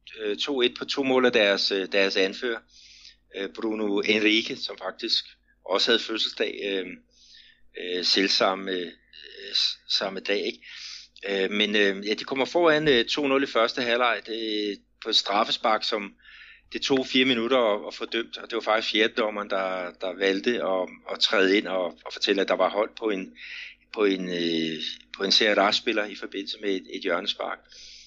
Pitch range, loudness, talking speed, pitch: 95-125 Hz, -25 LUFS, 155 wpm, 105 Hz